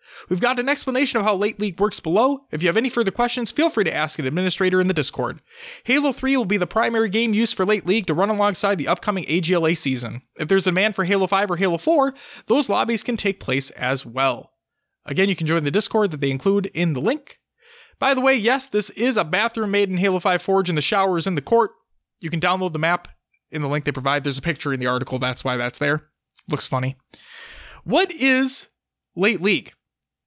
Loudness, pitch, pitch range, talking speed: -21 LUFS, 195 Hz, 160-230 Hz, 235 wpm